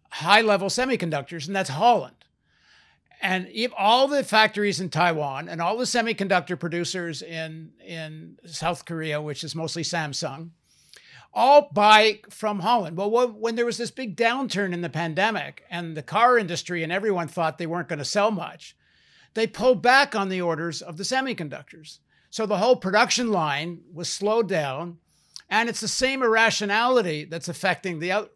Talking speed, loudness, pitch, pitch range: 165 wpm, -23 LUFS, 190 Hz, 165-225 Hz